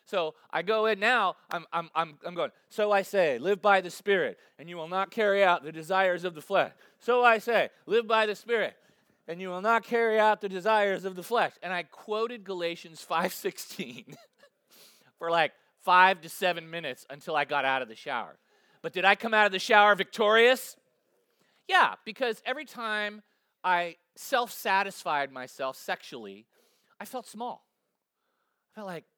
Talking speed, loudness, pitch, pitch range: 180 wpm, -27 LUFS, 195 Hz, 175-225 Hz